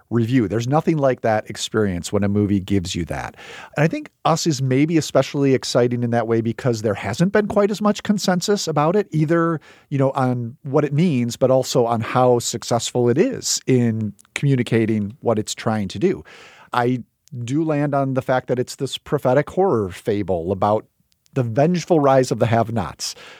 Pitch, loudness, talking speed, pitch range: 125 Hz, -20 LUFS, 185 wpm, 115-150 Hz